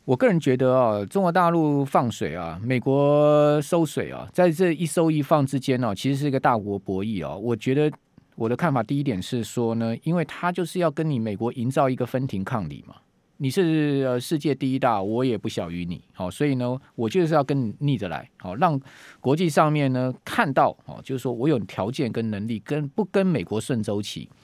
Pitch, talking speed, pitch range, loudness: 135 Hz, 310 characters per minute, 115-150 Hz, -24 LUFS